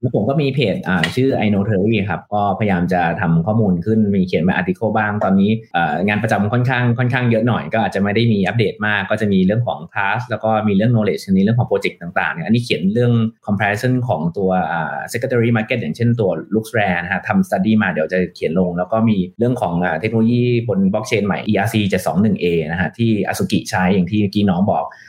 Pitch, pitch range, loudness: 105 Hz, 95-115 Hz, -17 LUFS